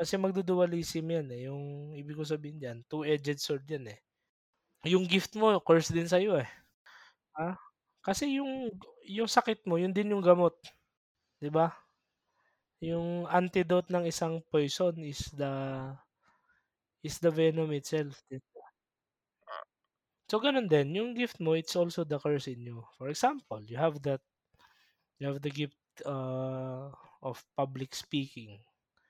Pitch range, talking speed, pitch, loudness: 140-180 Hz, 145 wpm, 160 Hz, -32 LUFS